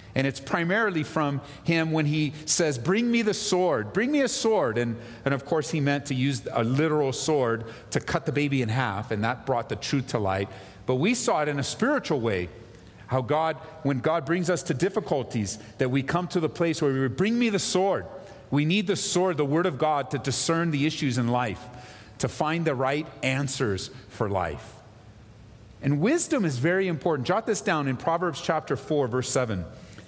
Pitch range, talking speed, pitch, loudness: 125-170 Hz, 205 wpm, 145 Hz, -26 LUFS